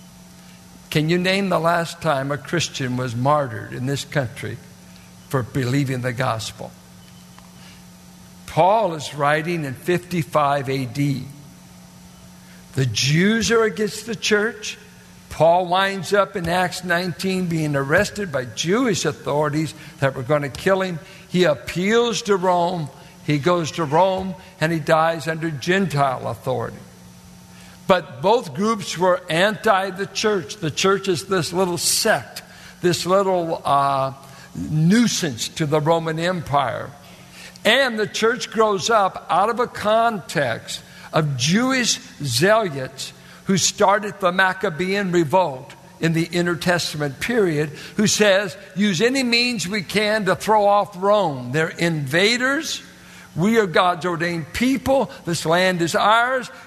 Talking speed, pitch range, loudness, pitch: 130 wpm, 140-195 Hz, -20 LUFS, 170 Hz